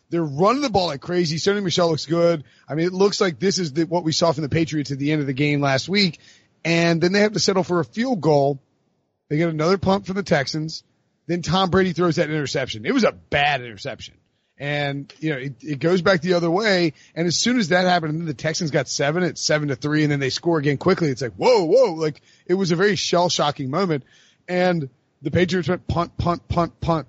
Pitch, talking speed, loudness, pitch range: 170 Hz, 250 wpm, -21 LUFS, 150-180 Hz